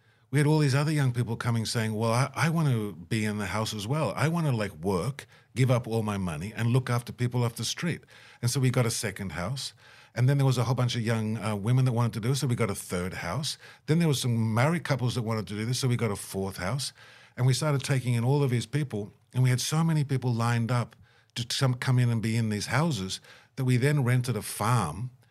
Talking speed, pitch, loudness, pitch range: 270 wpm, 120 Hz, -28 LUFS, 115-135 Hz